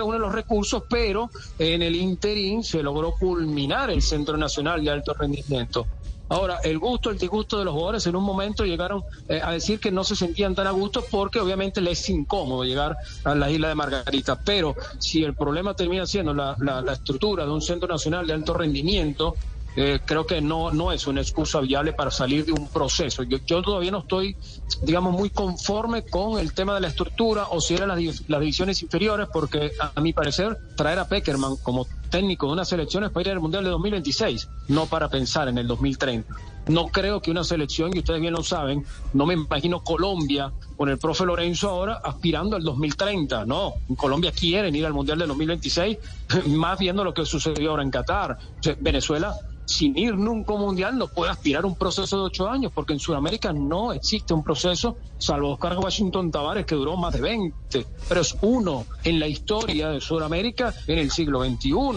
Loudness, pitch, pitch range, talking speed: -24 LUFS, 165 Hz, 150-195 Hz, 205 wpm